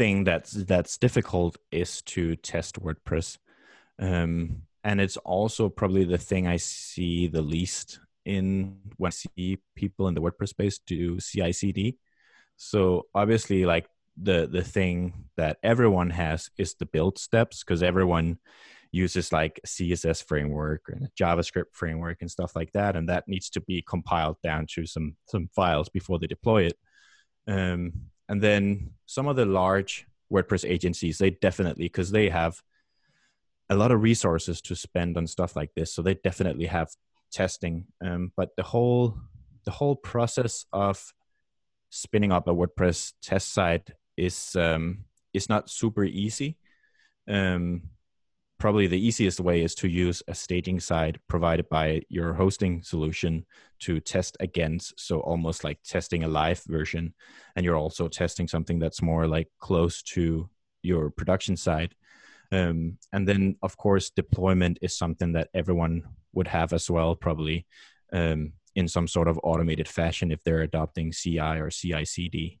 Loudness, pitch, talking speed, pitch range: -27 LUFS, 90 Hz, 155 wpm, 85-95 Hz